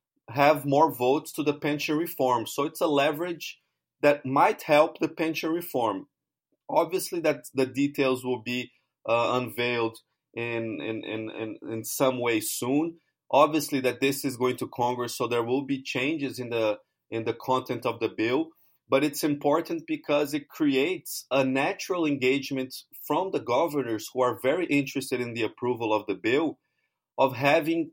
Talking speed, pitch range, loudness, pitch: 165 wpm, 125-155 Hz, -27 LUFS, 135 Hz